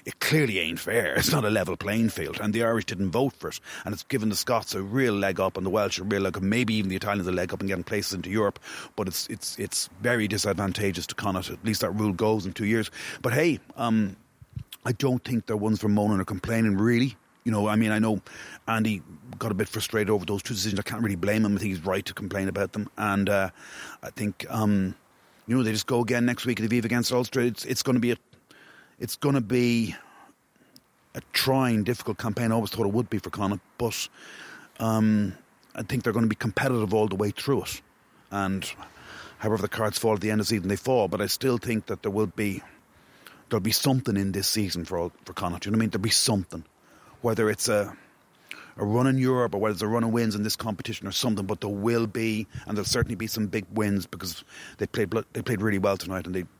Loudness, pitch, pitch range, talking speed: -27 LUFS, 110 Hz, 100-115 Hz, 250 wpm